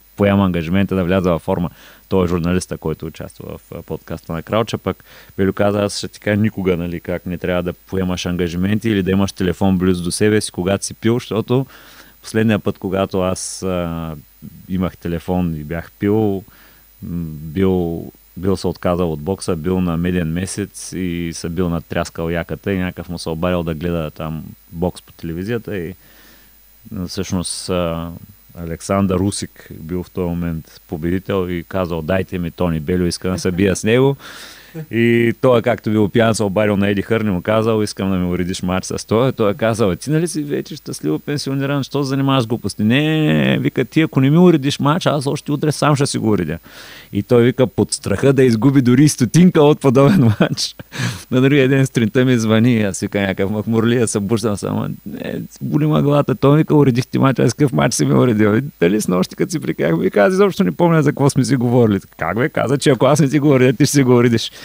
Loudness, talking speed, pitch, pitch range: -17 LUFS, 205 wpm, 100 Hz, 90-125 Hz